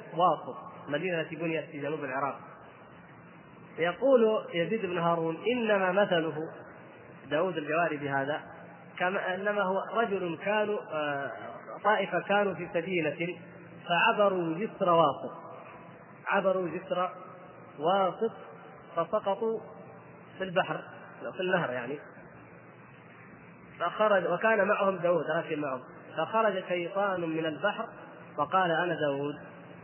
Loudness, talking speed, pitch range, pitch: -30 LUFS, 100 wpm, 160-195 Hz, 175 Hz